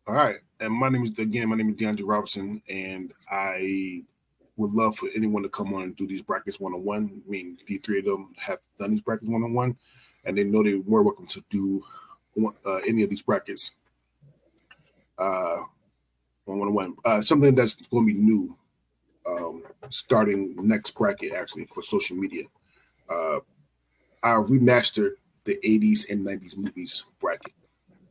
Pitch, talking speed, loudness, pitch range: 105 Hz, 170 wpm, -25 LUFS, 95-110 Hz